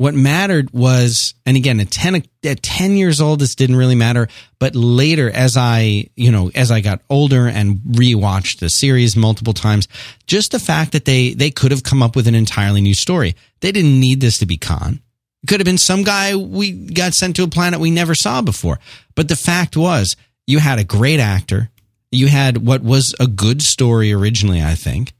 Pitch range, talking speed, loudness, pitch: 110-155 Hz, 210 wpm, -14 LUFS, 125 Hz